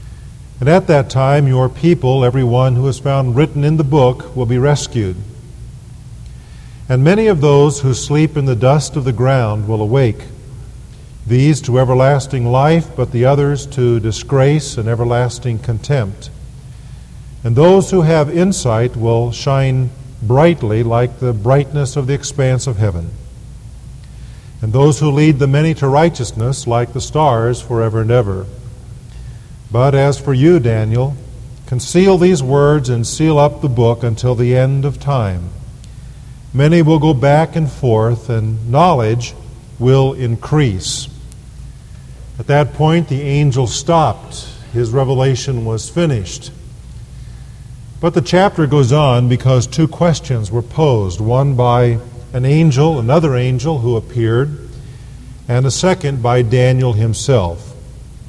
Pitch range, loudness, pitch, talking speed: 120-145 Hz, -14 LUFS, 130 Hz, 140 wpm